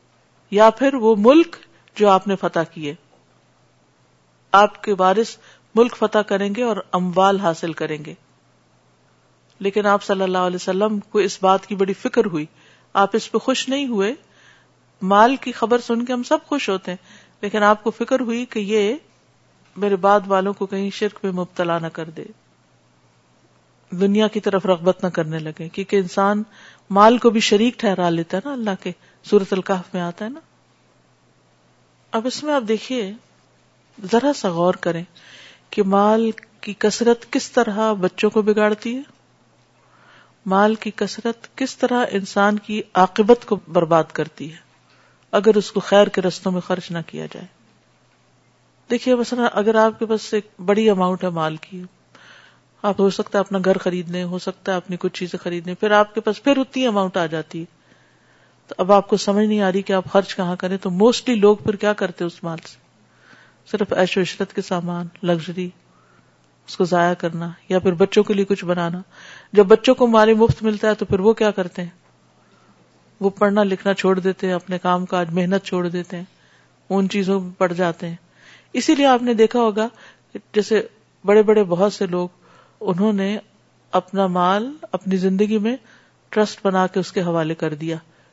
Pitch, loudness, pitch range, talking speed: 195 Hz, -19 LUFS, 180-215 Hz, 185 wpm